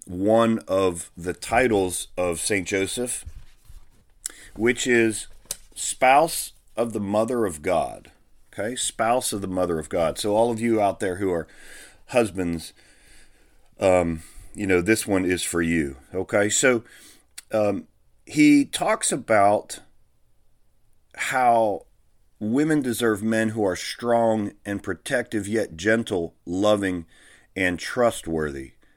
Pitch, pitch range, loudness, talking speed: 100 Hz, 90-115 Hz, -23 LUFS, 120 wpm